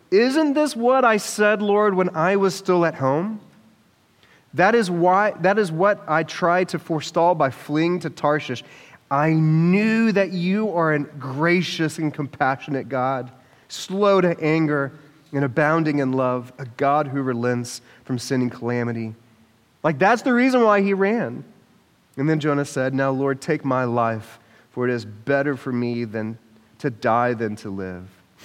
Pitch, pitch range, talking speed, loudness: 150 Hz, 125-180 Hz, 170 wpm, -21 LUFS